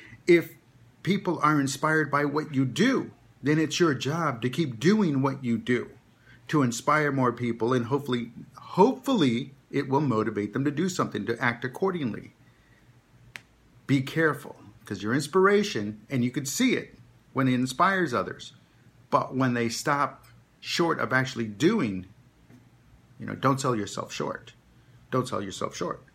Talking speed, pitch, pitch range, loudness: 155 wpm, 135 Hz, 120-155 Hz, -26 LUFS